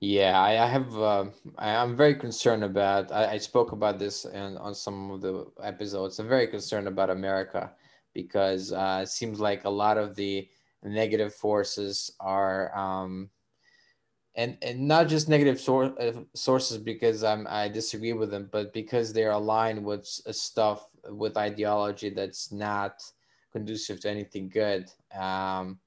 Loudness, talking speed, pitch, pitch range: -28 LUFS, 145 wpm, 105 Hz, 100-110 Hz